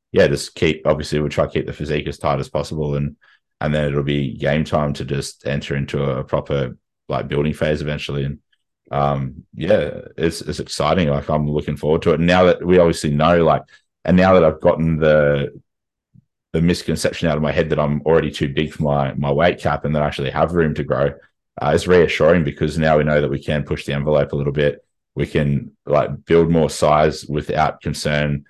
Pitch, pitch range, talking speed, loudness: 75 Hz, 70-80 Hz, 220 wpm, -18 LUFS